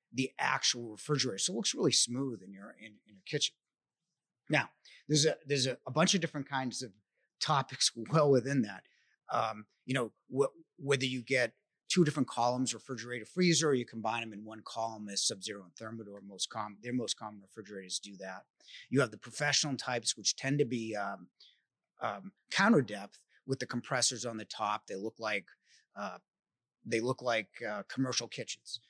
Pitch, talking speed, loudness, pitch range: 120 Hz, 185 wpm, -33 LUFS, 110-135 Hz